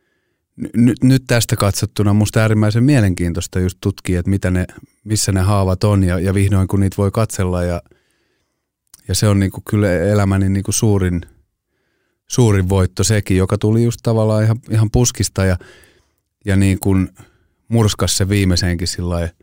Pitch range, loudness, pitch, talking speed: 95-110 Hz, -16 LUFS, 100 Hz, 150 wpm